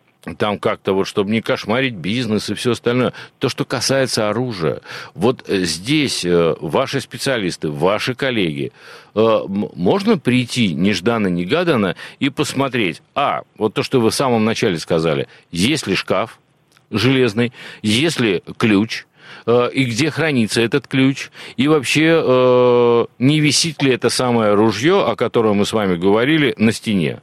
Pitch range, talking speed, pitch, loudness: 110-135 Hz, 135 wpm, 125 Hz, -17 LUFS